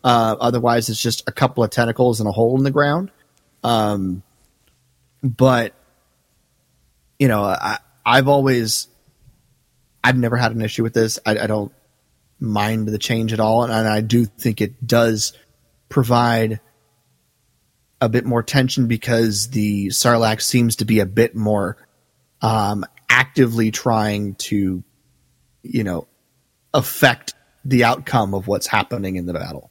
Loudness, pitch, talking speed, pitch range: -18 LUFS, 115 Hz, 145 wpm, 105-125 Hz